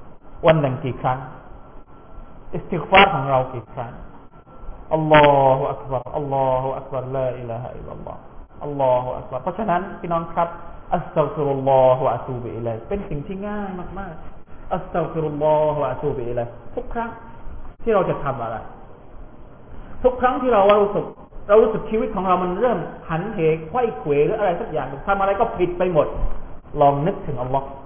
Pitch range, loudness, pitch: 130-190 Hz, -21 LUFS, 150 Hz